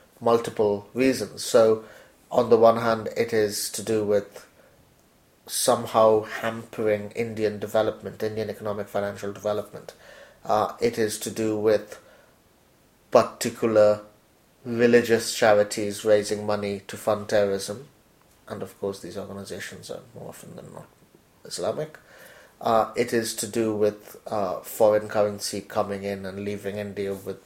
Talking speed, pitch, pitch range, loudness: 130 wpm, 105 Hz, 105-110 Hz, -24 LUFS